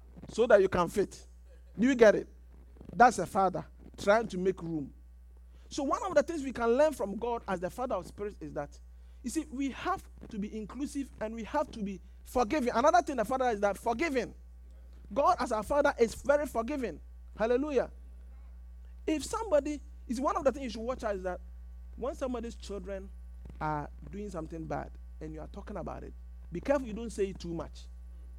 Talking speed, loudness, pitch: 200 wpm, -31 LUFS, 200 Hz